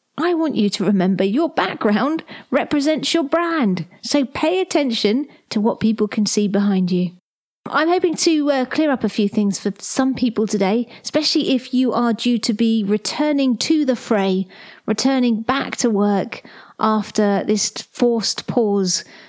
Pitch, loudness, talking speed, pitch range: 230 Hz, -19 LUFS, 160 wpm, 205-285 Hz